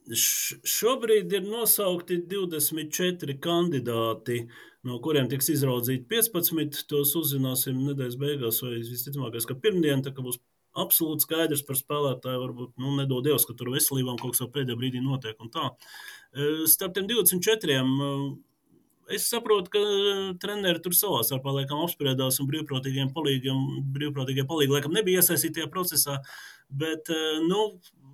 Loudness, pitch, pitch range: -26 LUFS, 145 Hz, 130-175 Hz